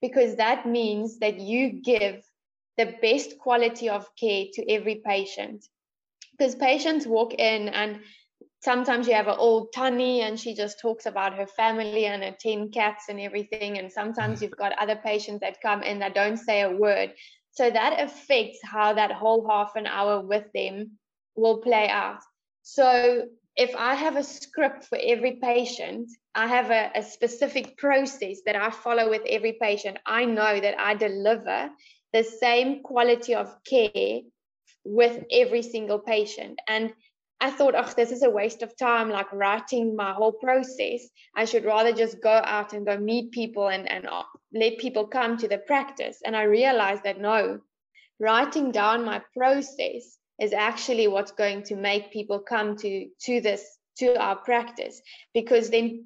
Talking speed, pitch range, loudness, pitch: 170 wpm, 210-245 Hz, -25 LUFS, 225 Hz